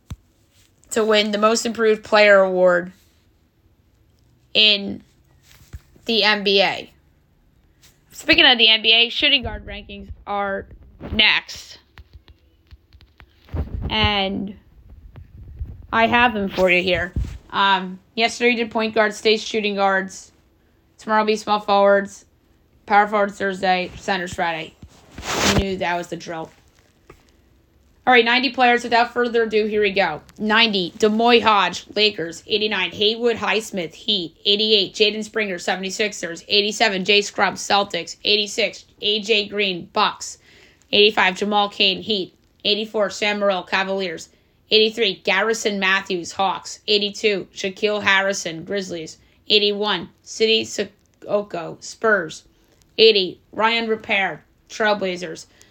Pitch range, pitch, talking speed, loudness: 175-215 Hz, 200 Hz, 110 wpm, -18 LUFS